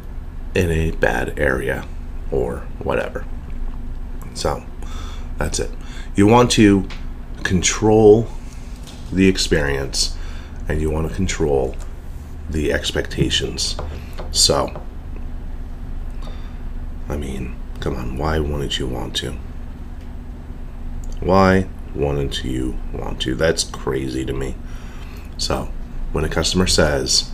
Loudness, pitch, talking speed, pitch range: -19 LUFS, 80 Hz, 100 wpm, 65-80 Hz